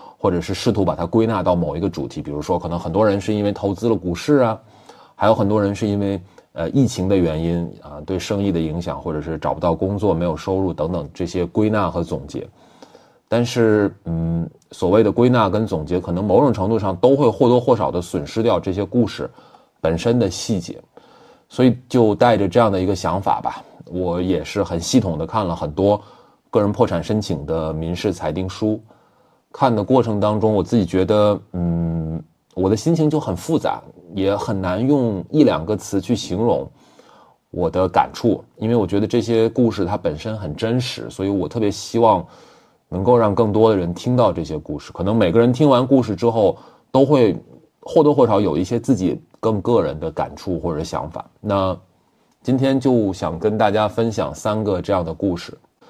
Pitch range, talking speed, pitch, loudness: 90-115 Hz, 285 characters per minute, 100 Hz, -19 LUFS